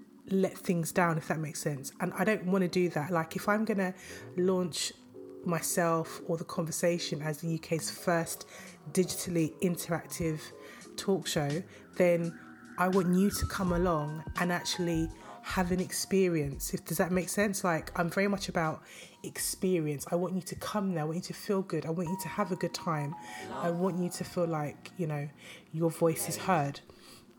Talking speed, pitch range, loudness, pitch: 190 wpm, 165-185 Hz, -32 LUFS, 175 Hz